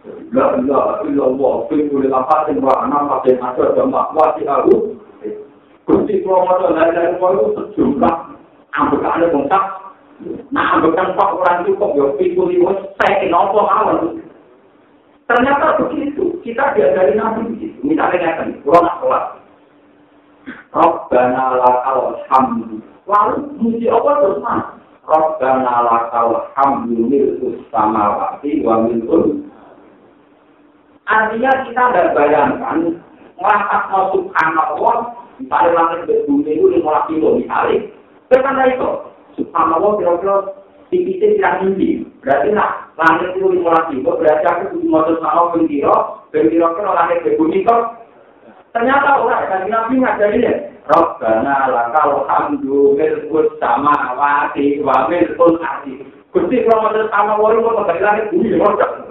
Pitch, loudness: 190 Hz, -15 LUFS